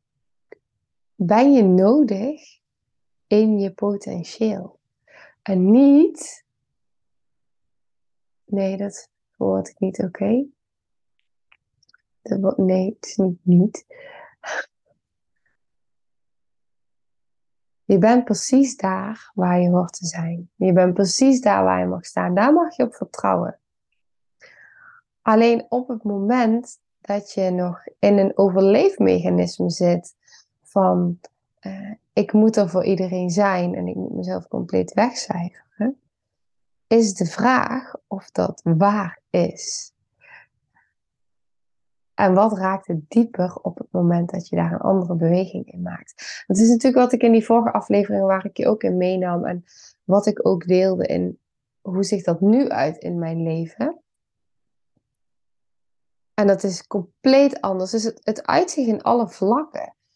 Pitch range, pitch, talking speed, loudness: 180-230 Hz, 195 Hz, 130 wpm, -20 LUFS